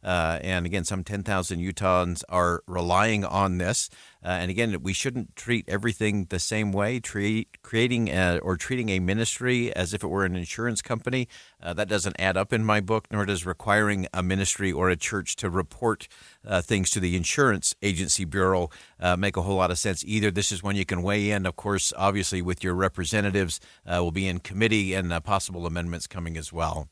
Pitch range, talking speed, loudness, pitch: 90-105 Hz, 205 wpm, -26 LUFS, 95 Hz